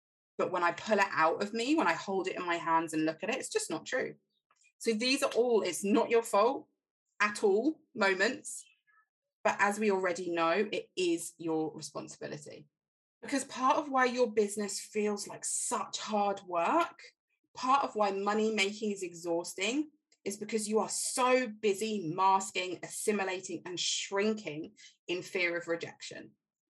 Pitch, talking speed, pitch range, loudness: 210 Hz, 170 wpm, 180-250 Hz, -32 LUFS